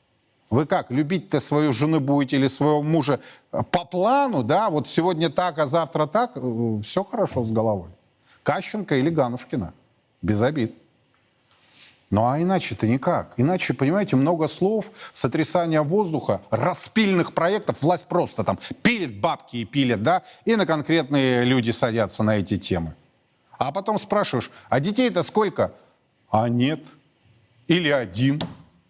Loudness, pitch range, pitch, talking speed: -23 LUFS, 120-180 Hz, 145 Hz, 135 wpm